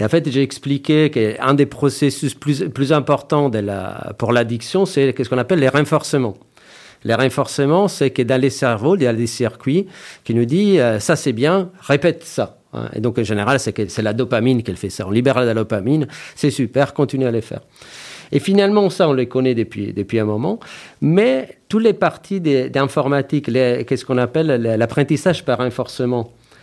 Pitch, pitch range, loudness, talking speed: 135 Hz, 120-150 Hz, -18 LUFS, 185 wpm